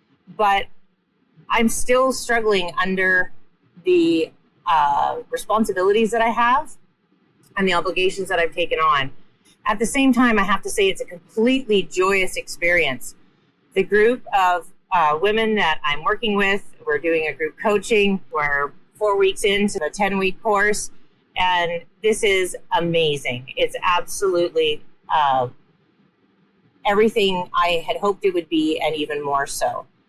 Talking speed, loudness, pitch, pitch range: 140 wpm, -20 LUFS, 195 Hz, 170-225 Hz